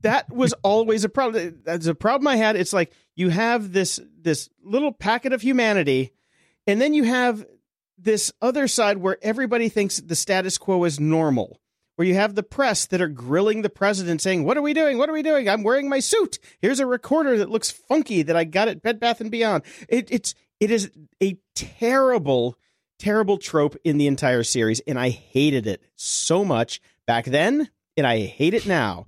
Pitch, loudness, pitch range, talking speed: 205 Hz, -22 LUFS, 165-240 Hz, 200 wpm